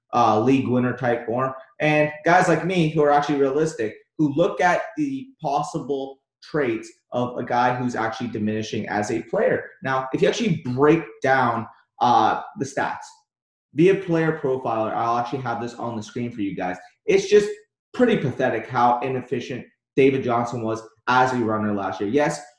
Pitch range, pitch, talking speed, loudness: 120-160 Hz, 135 Hz, 175 wpm, -22 LUFS